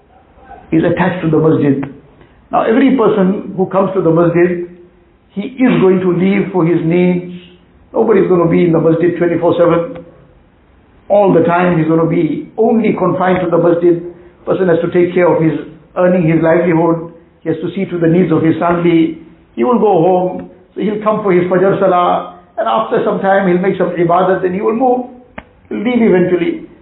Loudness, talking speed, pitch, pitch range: -12 LUFS, 195 wpm, 175 Hz, 165-190 Hz